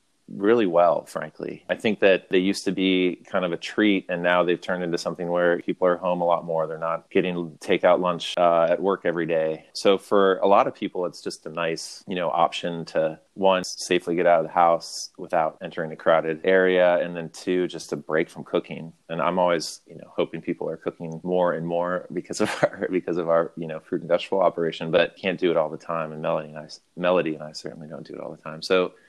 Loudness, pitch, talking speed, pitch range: -24 LUFS, 85 Hz, 245 wpm, 80-90 Hz